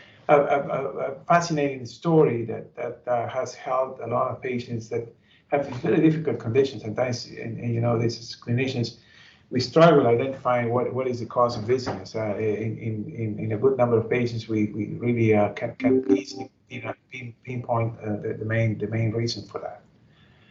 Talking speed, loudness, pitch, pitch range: 190 wpm, -25 LUFS, 120 Hz, 110-130 Hz